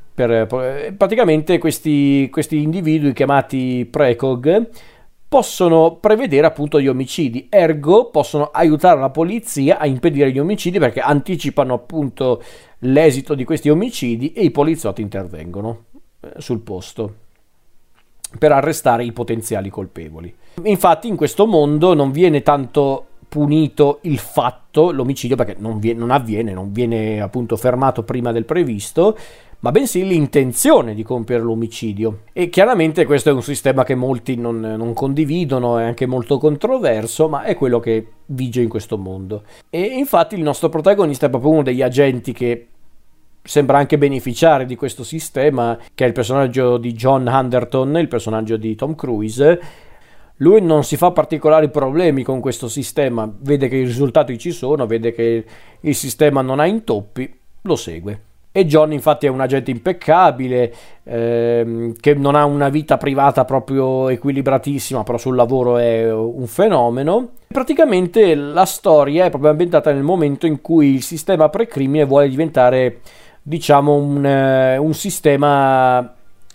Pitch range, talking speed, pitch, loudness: 120-155 Hz, 145 wpm, 135 Hz, -16 LUFS